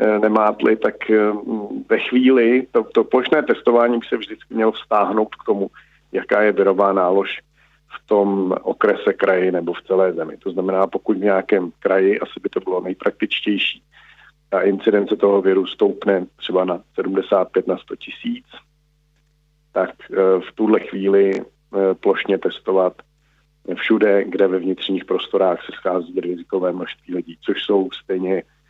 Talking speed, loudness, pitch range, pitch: 140 wpm, -19 LUFS, 95-115 Hz, 100 Hz